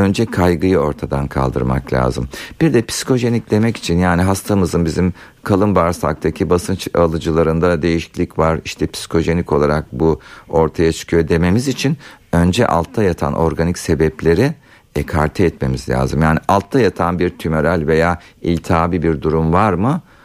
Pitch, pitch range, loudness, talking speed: 85 Hz, 80-95 Hz, -16 LUFS, 135 wpm